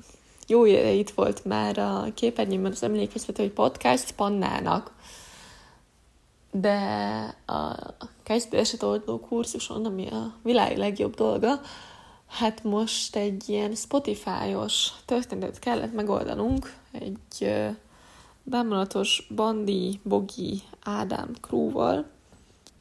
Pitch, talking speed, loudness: 210 Hz, 95 wpm, -27 LUFS